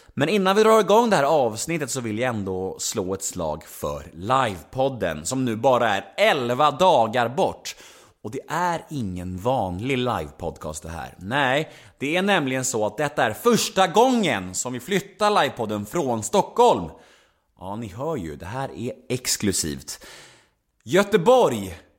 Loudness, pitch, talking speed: -22 LUFS, 130 Hz, 155 wpm